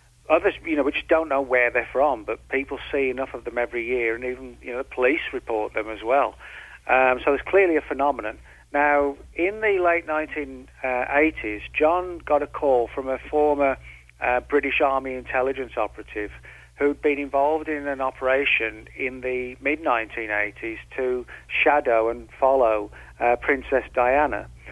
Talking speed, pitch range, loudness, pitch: 160 wpm, 120-145 Hz, -23 LUFS, 130 Hz